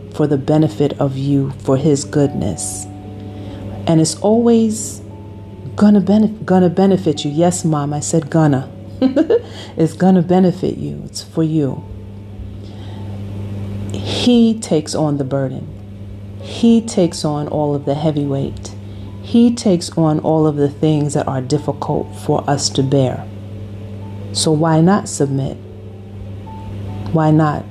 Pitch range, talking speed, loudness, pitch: 100-160 Hz, 130 wpm, -16 LUFS, 140 Hz